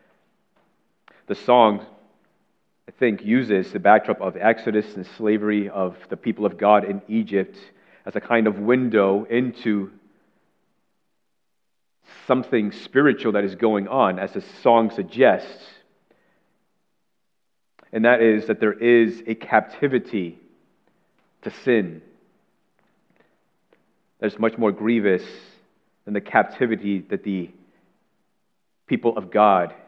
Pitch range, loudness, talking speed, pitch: 100-115 Hz, -21 LUFS, 115 wpm, 105 Hz